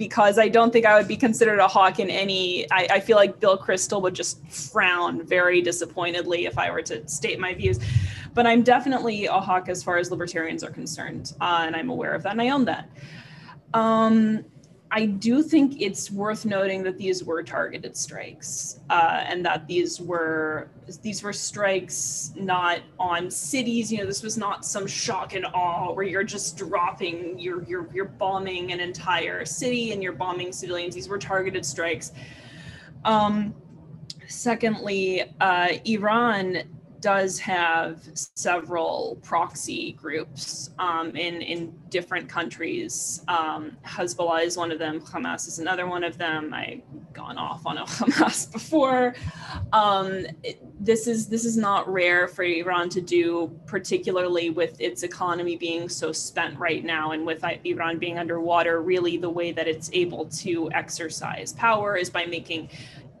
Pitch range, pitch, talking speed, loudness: 165-200 Hz, 180 Hz, 165 wpm, -24 LUFS